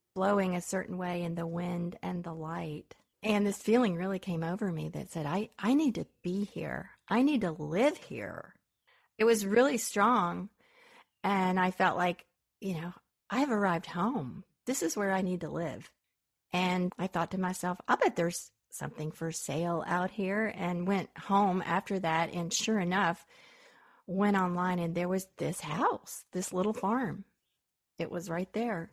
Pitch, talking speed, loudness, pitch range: 185 Hz, 175 wpm, -32 LUFS, 175-210 Hz